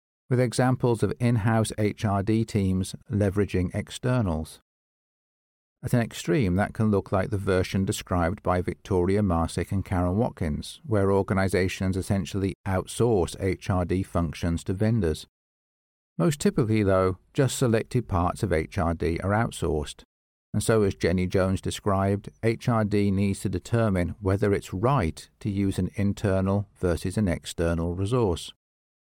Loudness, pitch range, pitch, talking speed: -26 LUFS, 90-110 Hz, 100 Hz, 130 wpm